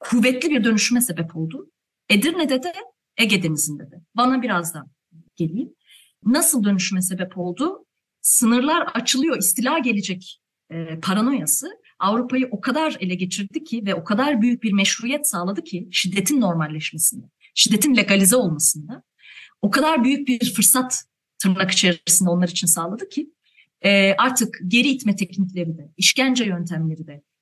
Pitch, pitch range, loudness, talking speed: 205 Hz, 180-255 Hz, -19 LUFS, 135 wpm